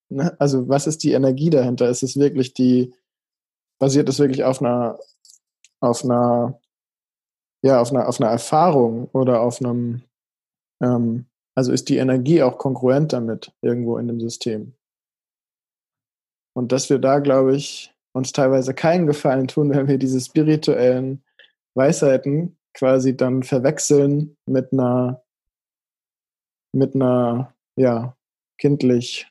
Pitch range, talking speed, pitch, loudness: 125-140 Hz, 130 wpm, 130 Hz, -19 LUFS